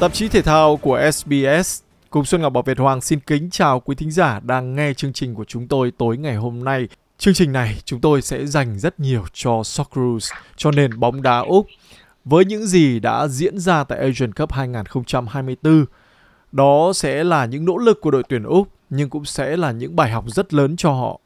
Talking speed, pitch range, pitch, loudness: 215 wpm, 125-155 Hz, 140 Hz, -18 LUFS